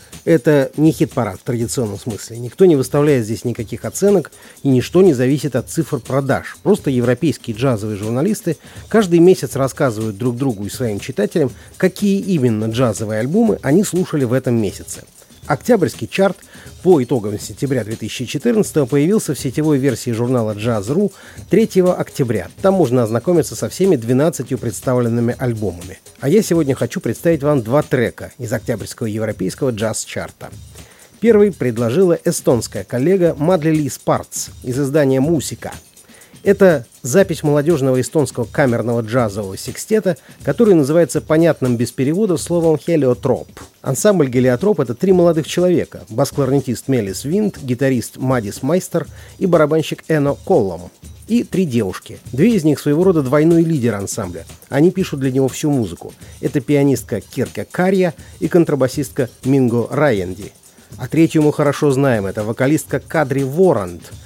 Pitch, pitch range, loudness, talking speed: 135 Hz, 120-165 Hz, -17 LUFS, 140 wpm